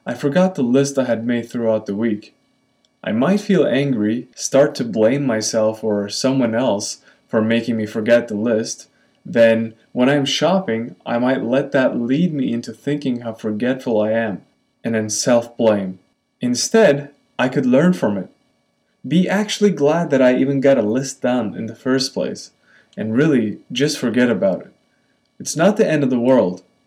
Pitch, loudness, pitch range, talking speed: 125 Hz, -18 LUFS, 115-140 Hz, 180 wpm